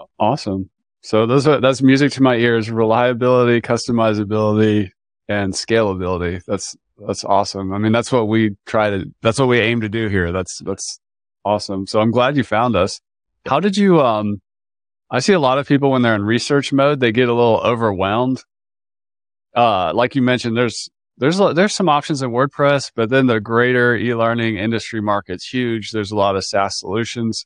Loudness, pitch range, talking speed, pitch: -17 LUFS, 105-130 Hz, 185 wpm, 115 Hz